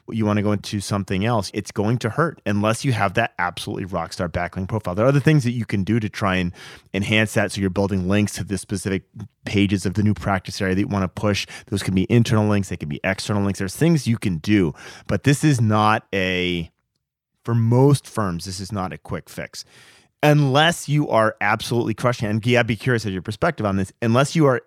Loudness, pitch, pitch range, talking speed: -21 LUFS, 105 Hz, 95-115 Hz, 235 wpm